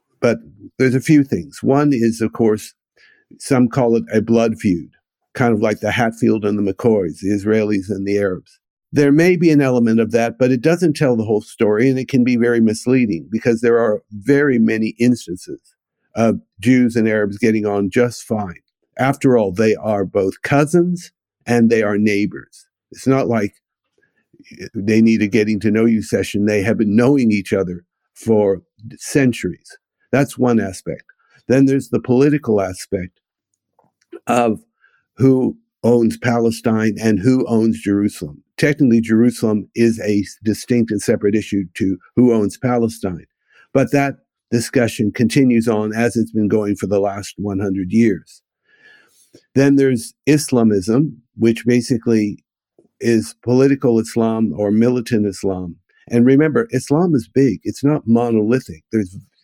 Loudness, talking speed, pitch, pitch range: -17 LUFS, 155 wpm, 115 Hz, 105-130 Hz